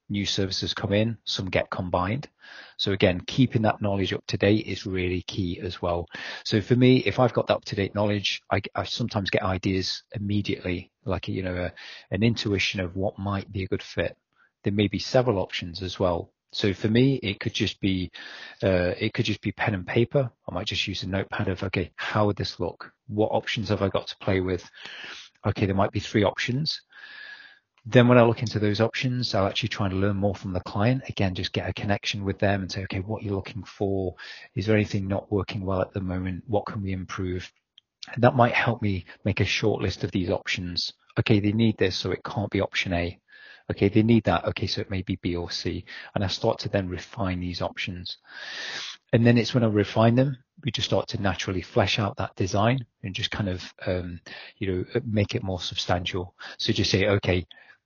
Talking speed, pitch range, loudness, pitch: 225 wpm, 95-115 Hz, -26 LUFS, 100 Hz